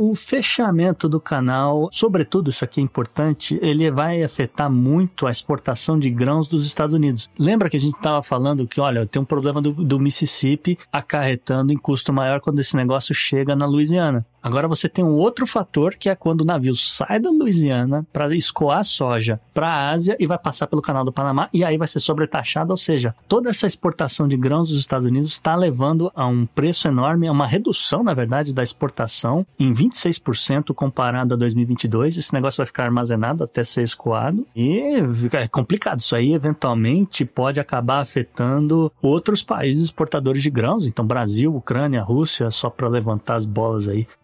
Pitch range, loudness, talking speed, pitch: 125-160 Hz, -20 LUFS, 185 wpm, 145 Hz